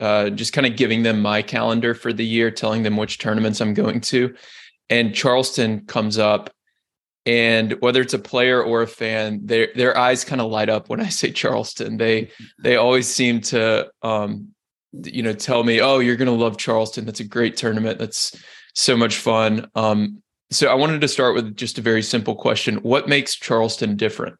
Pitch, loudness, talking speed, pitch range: 115 Hz, -19 LUFS, 200 wpm, 110-125 Hz